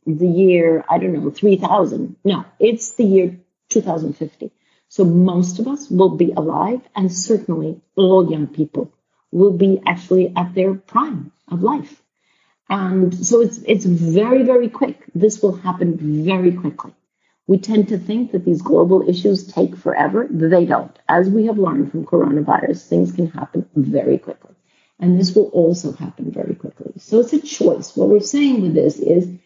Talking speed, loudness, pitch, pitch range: 175 wpm, -17 LUFS, 185 Hz, 175-215 Hz